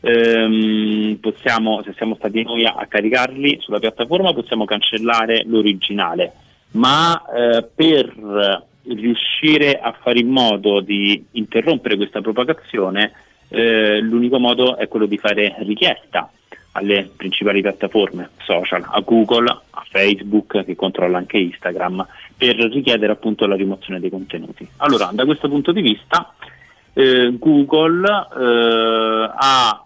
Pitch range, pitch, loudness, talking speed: 105-125 Hz, 115 Hz, -16 LUFS, 125 wpm